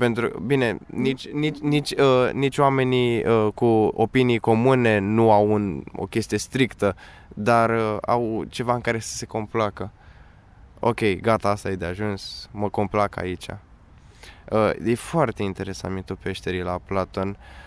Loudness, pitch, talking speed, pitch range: -23 LUFS, 110 Hz, 145 wpm, 95-120 Hz